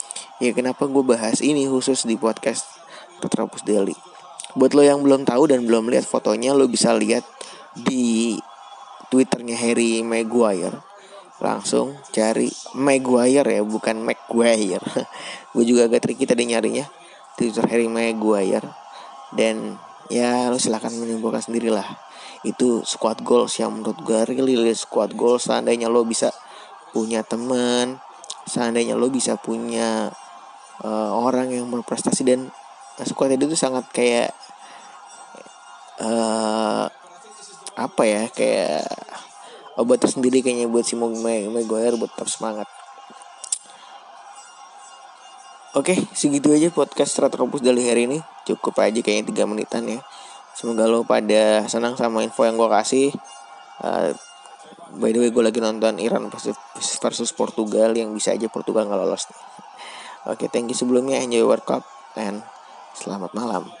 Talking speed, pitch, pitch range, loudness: 130 wpm, 115 Hz, 115-125 Hz, -21 LUFS